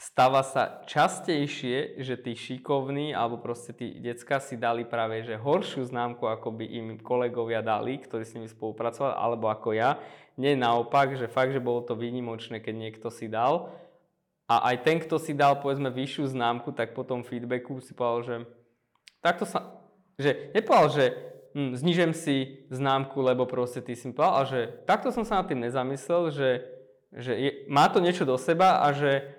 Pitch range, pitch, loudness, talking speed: 120-140 Hz, 130 Hz, -28 LUFS, 180 wpm